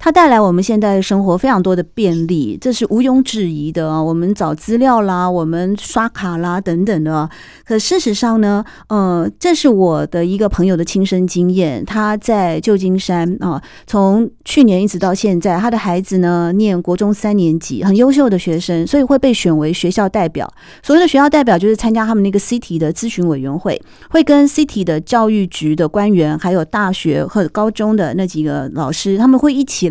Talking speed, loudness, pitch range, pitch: 310 characters per minute, -14 LUFS, 175-225 Hz, 195 Hz